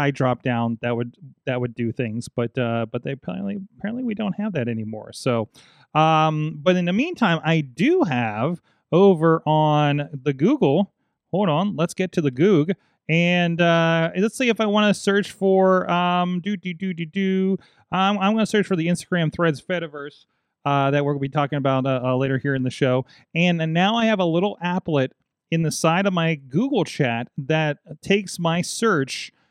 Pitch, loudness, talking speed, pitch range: 165 Hz, -21 LUFS, 200 wpm, 140-190 Hz